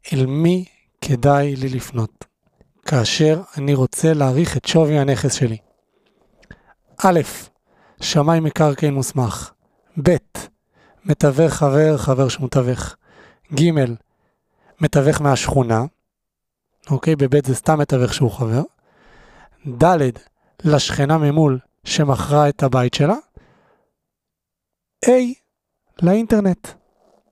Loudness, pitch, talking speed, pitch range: -18 LUFS, 140 Hz, 95 wpm, 130-155 Hz